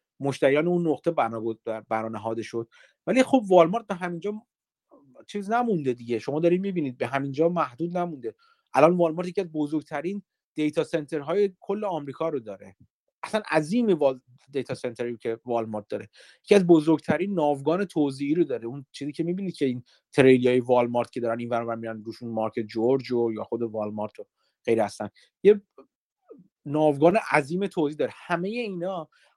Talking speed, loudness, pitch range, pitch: 155 wpm, -25 LUFS, 120-180 Hz, 150 Hz